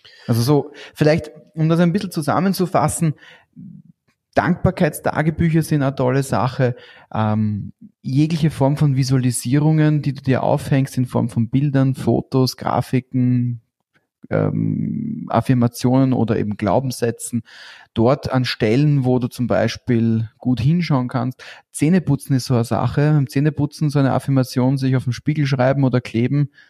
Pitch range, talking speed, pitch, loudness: 120-150 Hz, 135 wpm, 130 Hz, -19 LUFS